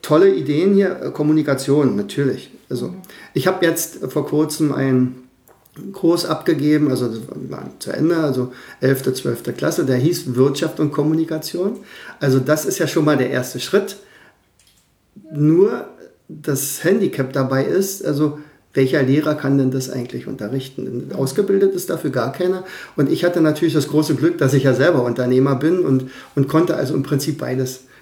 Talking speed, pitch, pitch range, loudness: 160 wpm, 150 Hz, 130-165 Hz, -18 LUFS